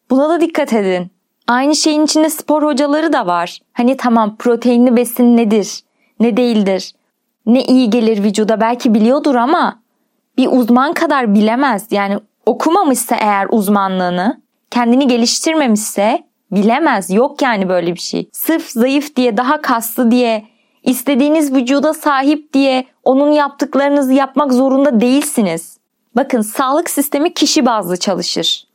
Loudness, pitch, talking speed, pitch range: -13 LUFS, 250 Hz, 130 wpm, 225-285 Hz